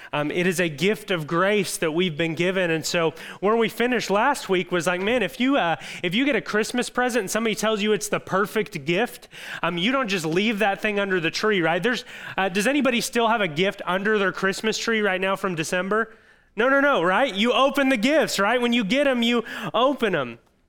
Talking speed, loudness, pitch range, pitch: 235 wpm, -22 LUFS, 180-235 Hz, 205 Hz